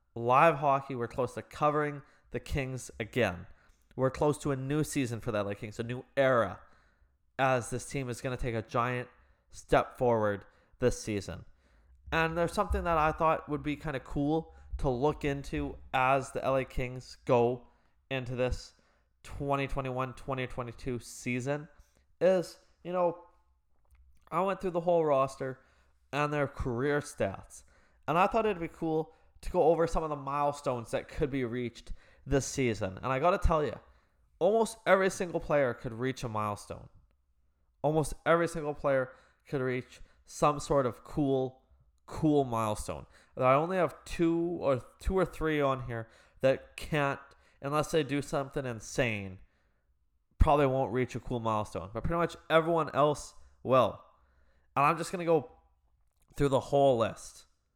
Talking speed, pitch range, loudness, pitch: 160 wpm, 115-150 Hz, -31 LUFS, 130 Hz